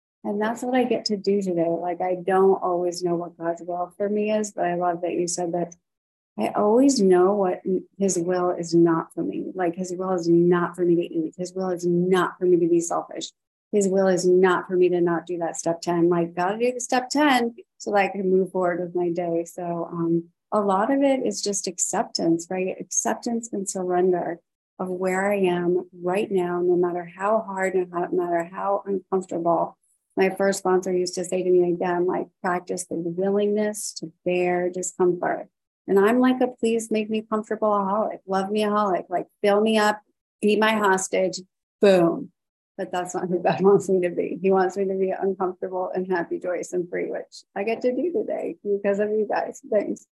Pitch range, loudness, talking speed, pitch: 175-205 Hz, -23 LUFS, 210 wpm, 185 Hz